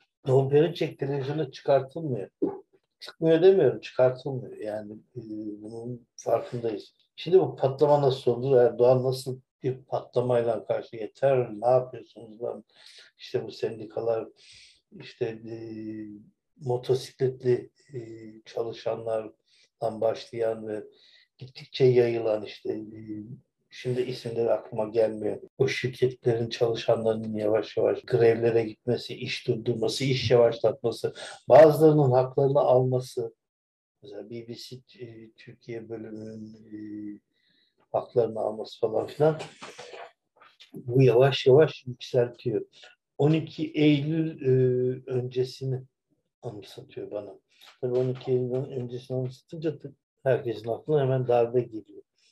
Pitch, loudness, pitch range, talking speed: 125 Hz, -26 LUFS, 115-135 Hz, 95 wpm